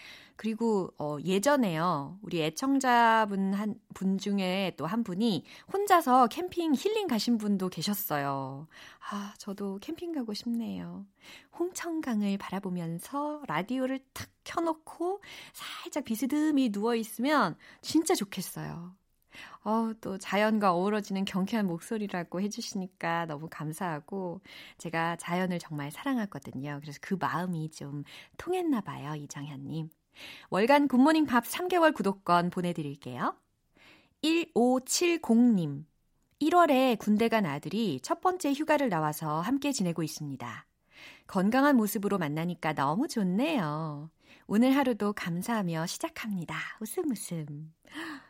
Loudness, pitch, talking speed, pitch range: -30 LUFS, 205 Hz, 270 characters per minute, 170-265 Hz